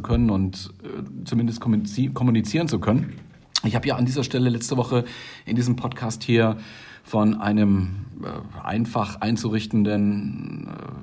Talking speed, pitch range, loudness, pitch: 130 wpm, 105-120 Hz, -23 LUFS, 115 Hz